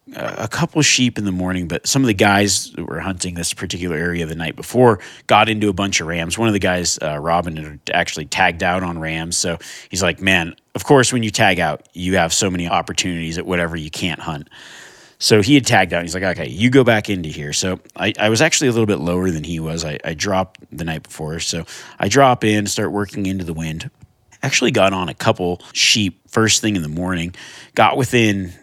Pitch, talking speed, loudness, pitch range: 95 Hz, 235 wpm, -17 LUFS, 85-105 Hz